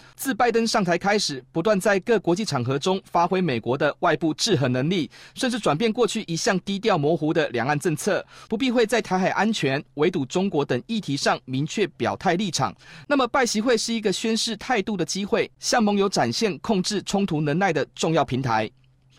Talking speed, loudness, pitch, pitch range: 305 characters per minute, -23 LUFS, 185 Hz, 150-220 Hz